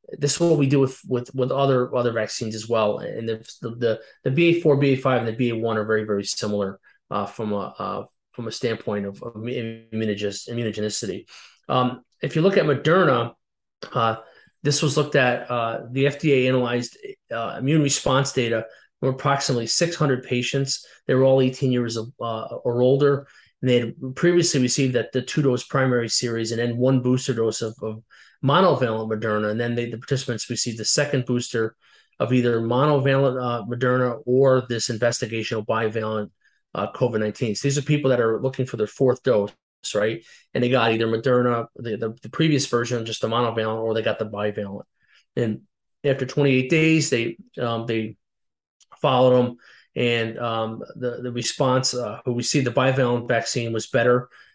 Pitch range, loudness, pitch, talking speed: 115-135 Hz, -22 LUFS, 125 Hz, 180 wpm